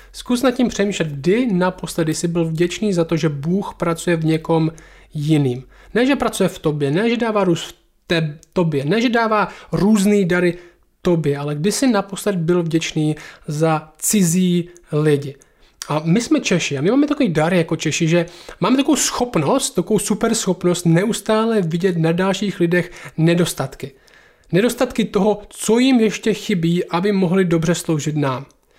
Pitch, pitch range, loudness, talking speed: 175 Hz, 165-210 Hz, -18 LUFS, 165 wpm